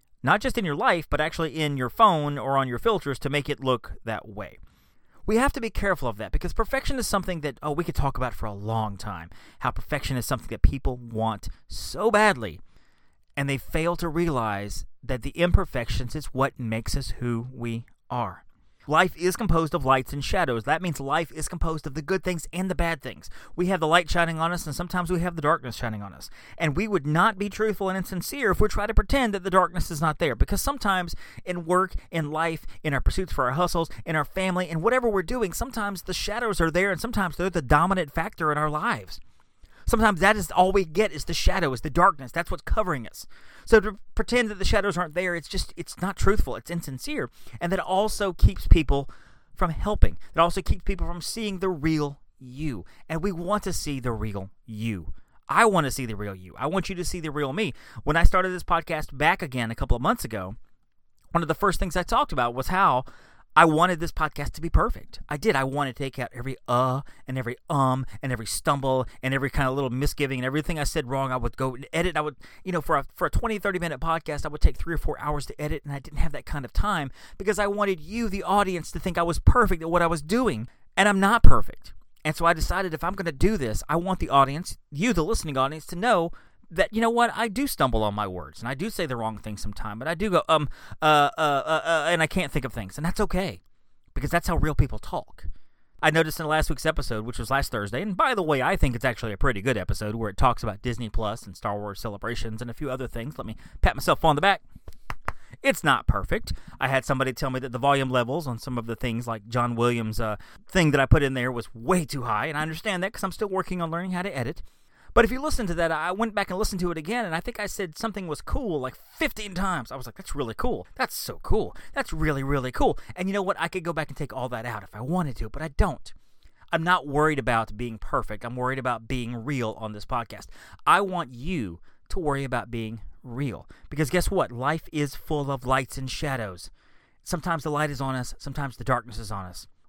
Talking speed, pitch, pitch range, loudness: 250 wpm, 150 Hz, 125-180 Hz, -26 LUFS